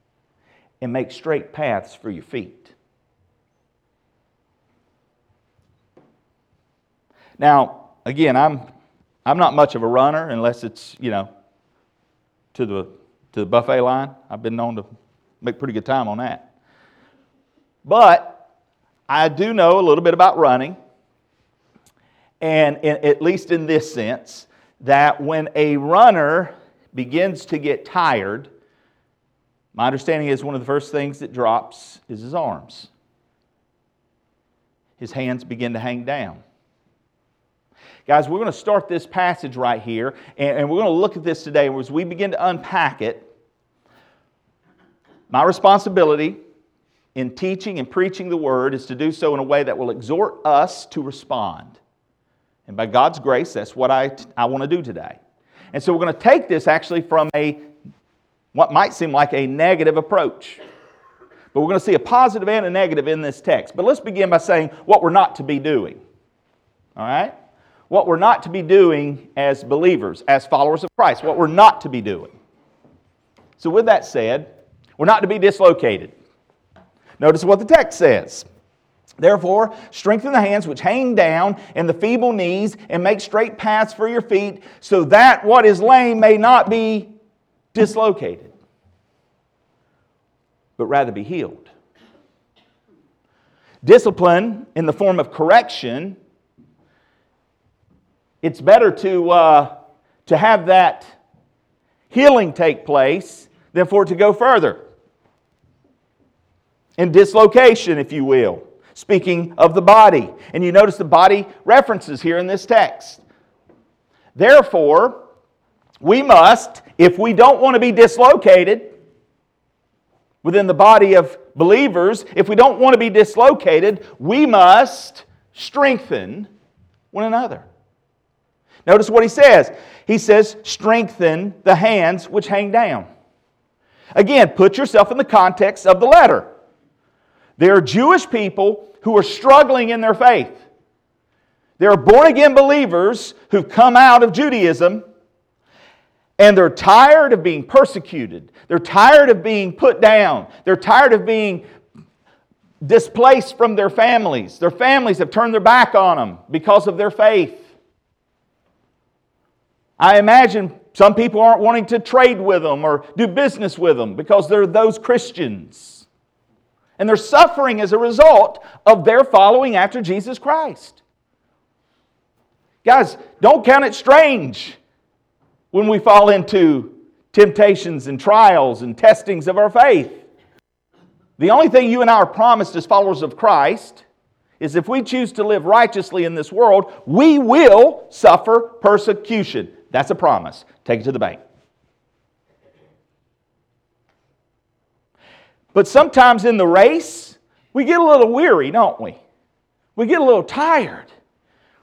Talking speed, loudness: 145 wpm, -14 LUFS